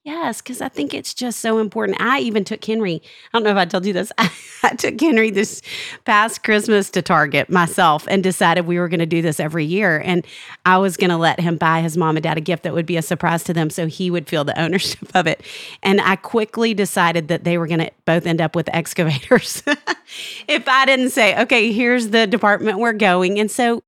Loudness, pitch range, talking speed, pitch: -17 LUFS, 170-220 Hz, 240 wpm, 185 Hz